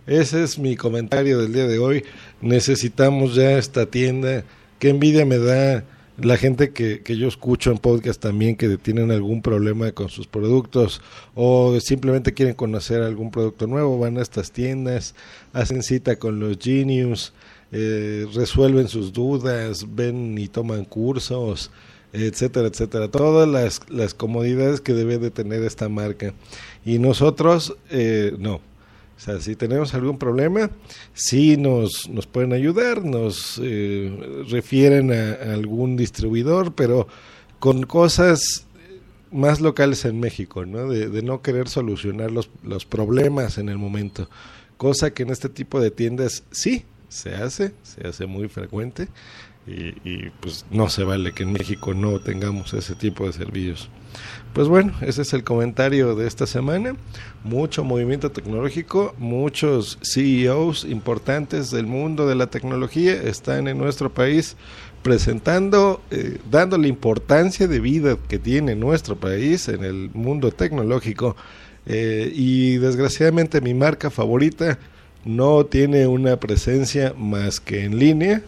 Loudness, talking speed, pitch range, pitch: -20 LUFS, 145 wpm, 110-135 Hz, 120 Hz